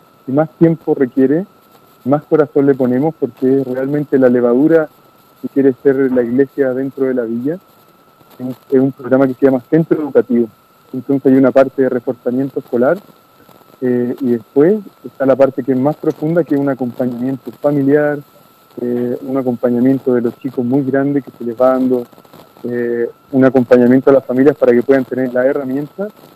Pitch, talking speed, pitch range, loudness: 135 Hz, 175 wpm, 125-145 Hz, -14 LUFS